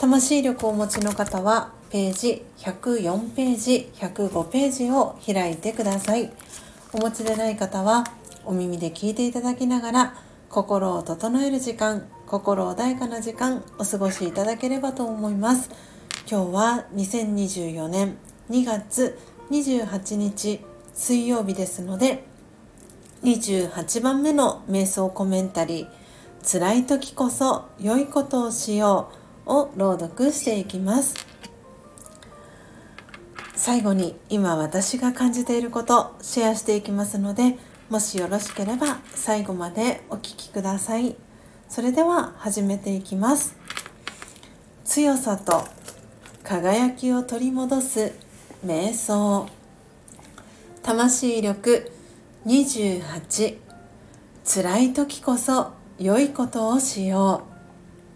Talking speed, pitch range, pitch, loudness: 210 characters per minute, 195-250 Hz, 220 Hz, -23 LUFS